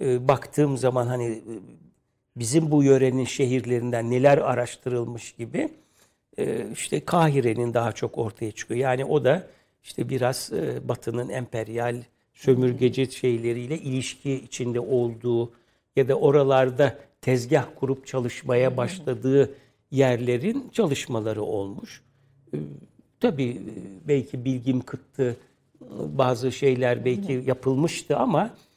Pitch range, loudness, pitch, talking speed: 120-135 Hz, -25 LUFS, 130 Hz, 100 wpm